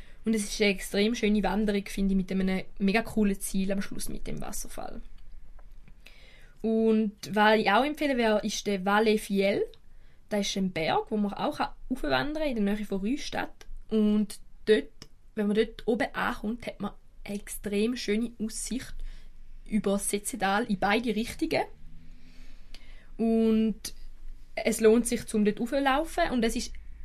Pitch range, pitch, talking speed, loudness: 200-225 Hz, 215 Hz, 160 wpm, -28 LUFS